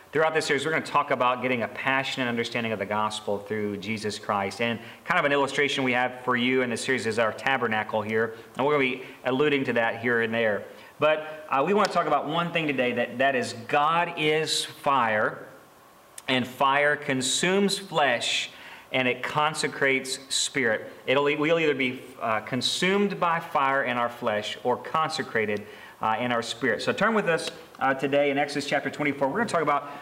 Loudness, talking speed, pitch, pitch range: -25 LUFS, 200 wpm, 135 Hz, 120-150 Hz